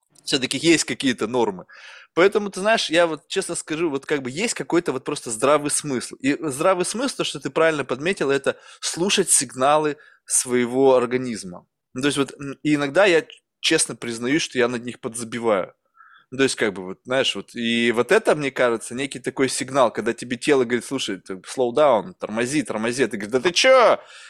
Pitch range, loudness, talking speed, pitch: 125-165 Hz, -21 LUFS, 190 wpm, 140 Hz